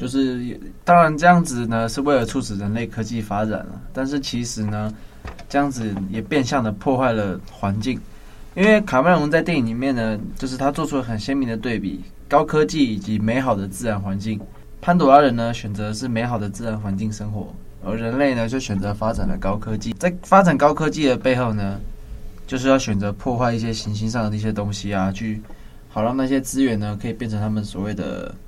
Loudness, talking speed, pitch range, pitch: -21 LUFS, 310 characters per minute, 105-135 Hz, 115 Hz